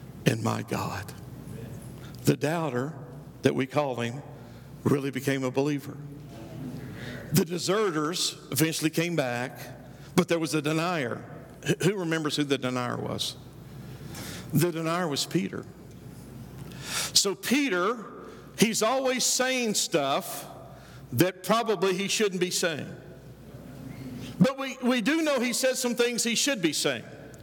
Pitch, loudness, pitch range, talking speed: 160 Hz, -27 LUFS, 135-195 Hz, 125 wpm